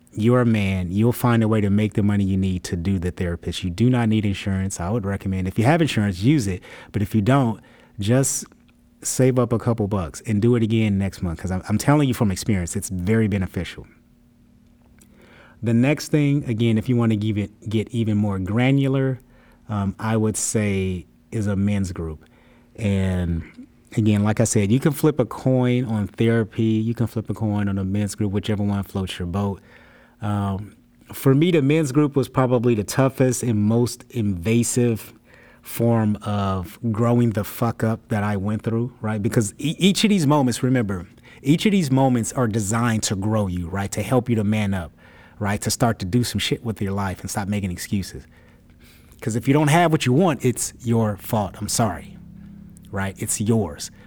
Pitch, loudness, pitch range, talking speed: 110 Hz, -21 LUFS, 100-120 Hz, 200 wpm